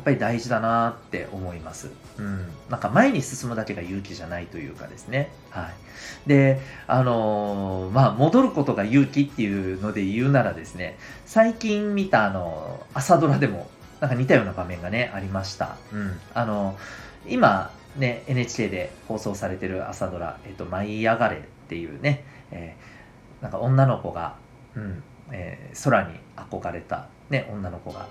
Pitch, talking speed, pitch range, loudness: 110 Hz, 325 characters per minute, 95-135 Hz, -24 LUFS